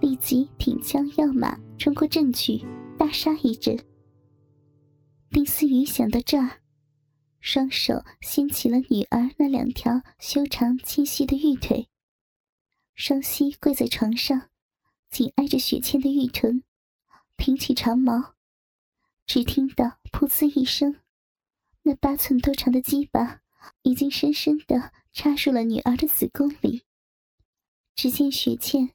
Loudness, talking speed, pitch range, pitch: -23 LUFS, 185 characters per minute, 245-285 Hz, 270 Hz